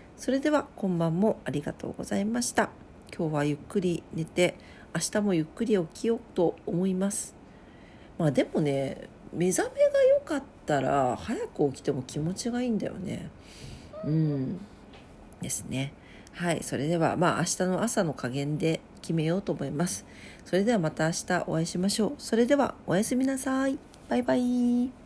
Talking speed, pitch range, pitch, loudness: 325 characters per minute, 160-235 Hz, 180 Hz, -28 LUFS